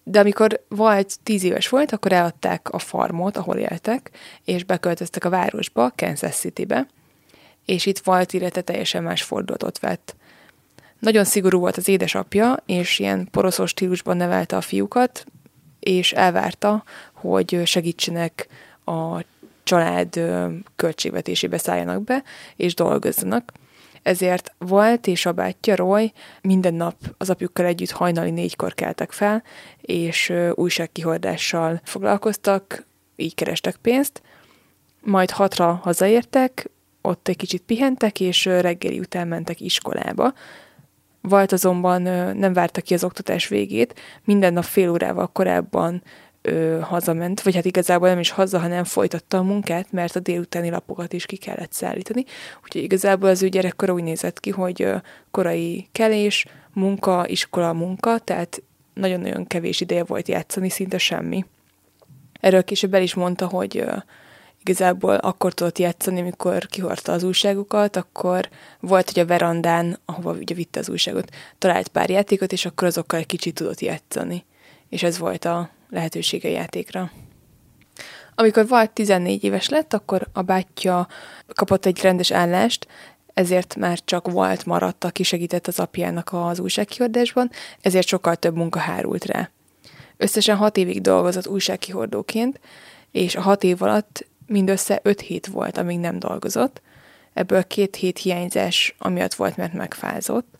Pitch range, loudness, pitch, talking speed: 175-195 Hz, -21 LUFS, 185 Hz, 140 wpm